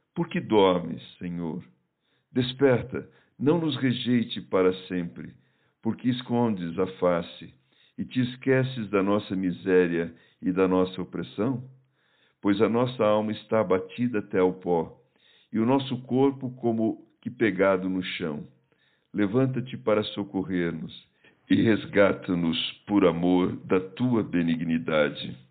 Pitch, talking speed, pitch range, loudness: 105 Hz, 120 wpm, 90-125 Hz, -26 LUFS